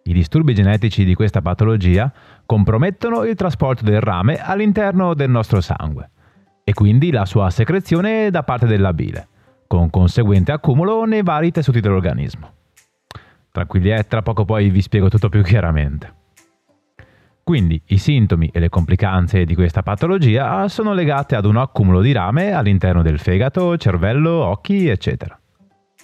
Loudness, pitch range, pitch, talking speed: -16 LUFS, 95-145 Hz, 110 Hz, 145 wpm